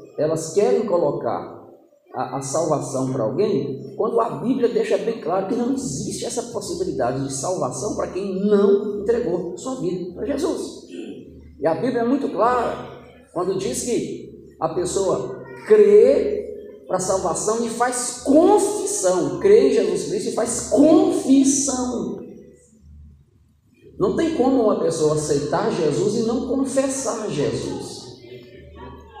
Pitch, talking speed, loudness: 245 Hz, 135 wpm, -20 LUFS